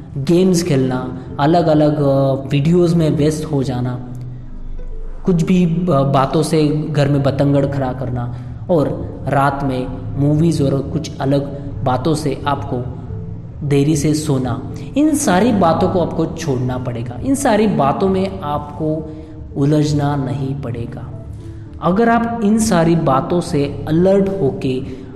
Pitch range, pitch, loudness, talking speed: 130-160 Hz, 140 Hz, -16 LUFS, 130 wpm